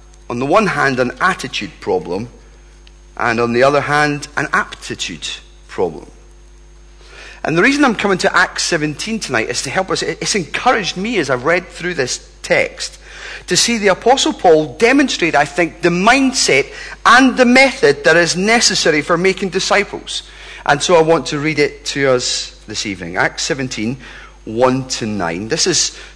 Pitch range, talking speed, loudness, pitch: 140-235 Hz, 170 wpm, -14 LUFS, 175 Hz